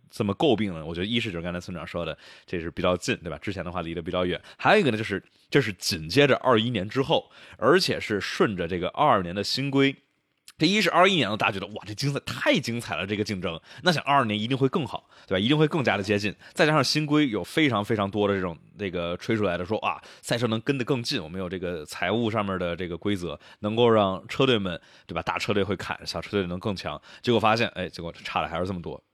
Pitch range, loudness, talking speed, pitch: 90-120 Hz, -25 LUFS, 380 characters per minute, 105 Hz